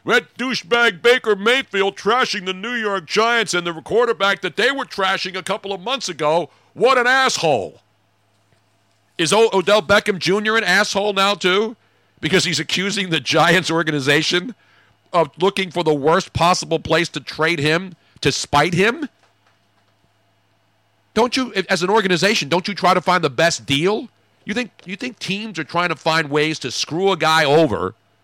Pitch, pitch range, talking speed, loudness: 180 Hz, 155-205 Hz, 170 wpm, -18 LUFS